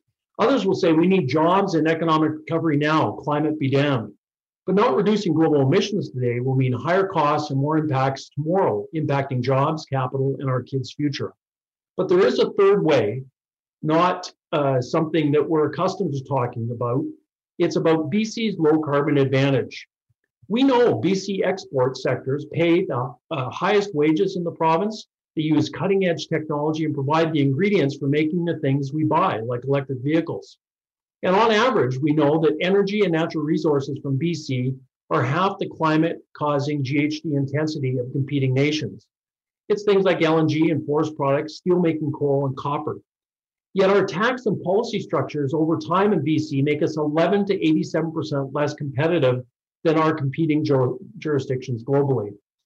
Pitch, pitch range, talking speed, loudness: 155 Hz, 140-170 Hz, 165 wpm, -21 LUFS